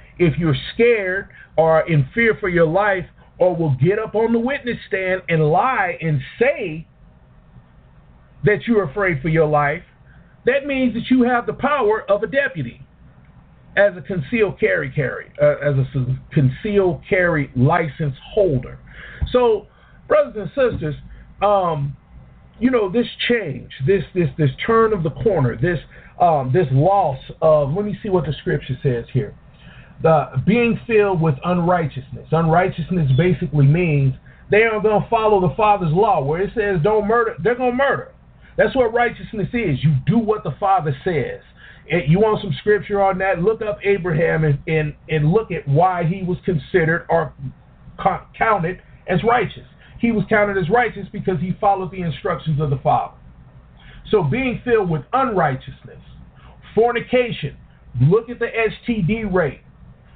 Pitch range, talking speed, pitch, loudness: 150-215 Hz, 160 wpm, 180 Hz, -19 LUFS